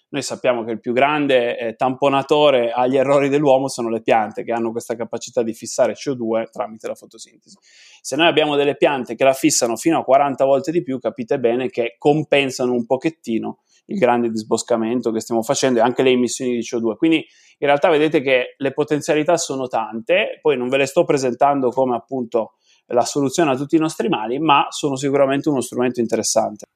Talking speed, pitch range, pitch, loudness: 190 wpm, 120-145 Hz, 135 Hz, -18 LUFS